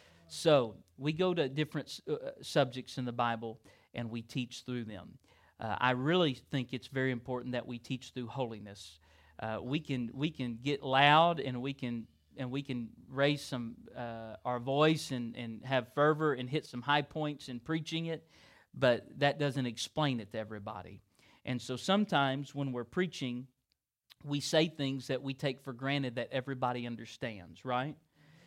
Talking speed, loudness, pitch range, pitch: 175 wpm, -34 LUFS, 120-145 Hz, 130 Hz